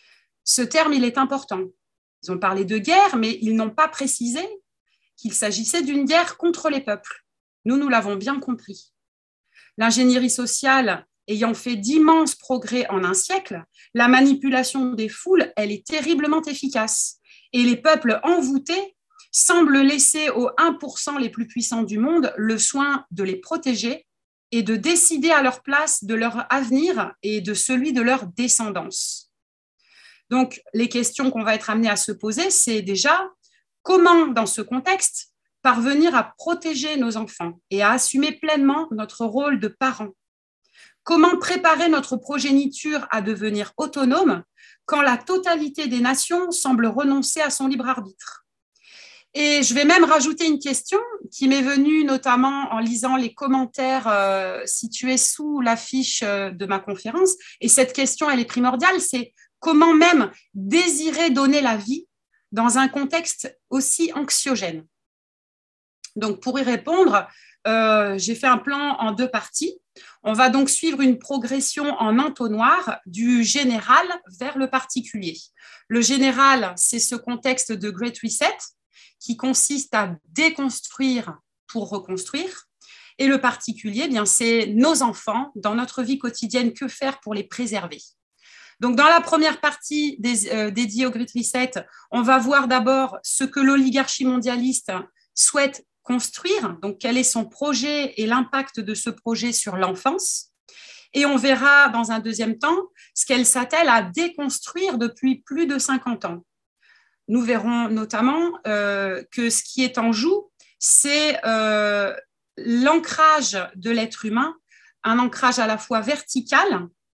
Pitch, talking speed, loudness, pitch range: 255 Hz, 150 wpm, -20 LUFS, 225-295 Hz